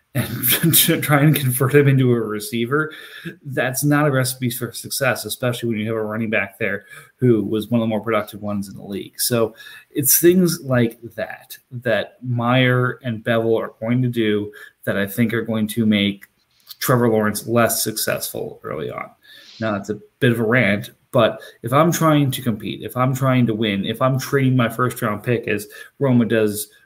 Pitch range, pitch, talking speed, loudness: 110-130 Hz, 115 Hz, 195 wpm, -19 LUFS